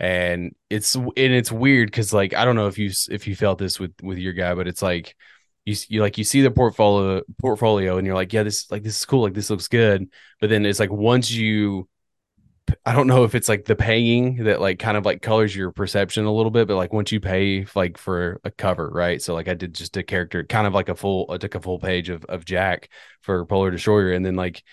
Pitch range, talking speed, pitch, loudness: 90-110 Hz, 255 wpm, 100 Hz, -21 LUFS